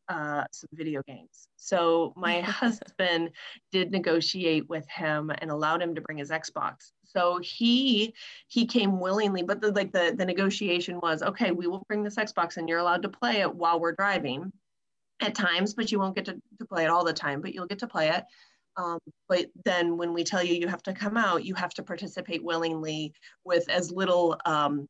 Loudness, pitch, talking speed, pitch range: -28 LUFS, 175 Hz, 205 wpm, 165-195 Hz